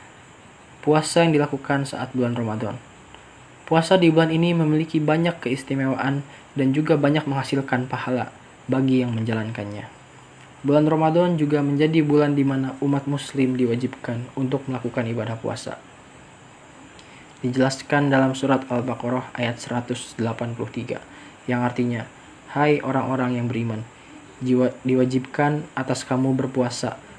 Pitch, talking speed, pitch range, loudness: 130 Hz, 115 wpm, 125-145 Hz, -22 LUFS